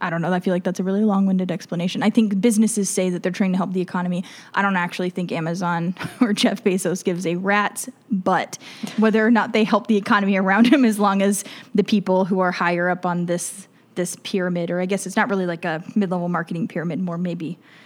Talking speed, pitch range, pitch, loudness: 230 wpm, 175-205 Hz, 190 Hz, -21 LUFS